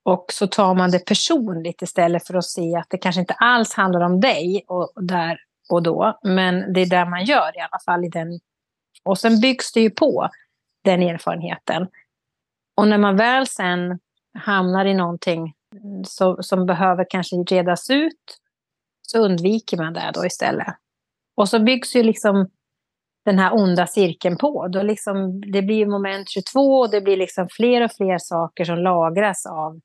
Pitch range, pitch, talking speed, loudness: 180-210 Hz, 190 Hz, 175 wpm, -19 LUFS